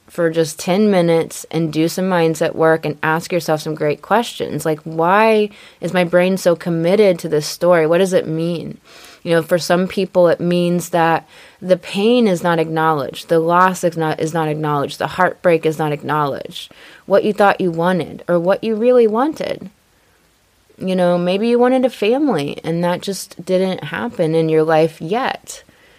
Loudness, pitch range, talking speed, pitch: -16 LUFS, 160-190 Hz, 185 wpm, 175 Hz